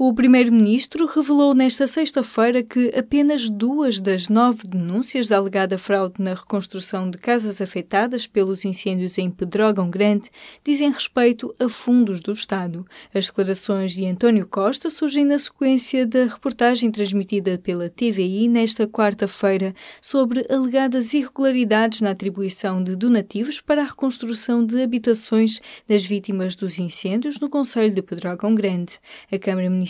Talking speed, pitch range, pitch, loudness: 130 wpm, 195-250 Hz, 220 Hz, -20 LUFS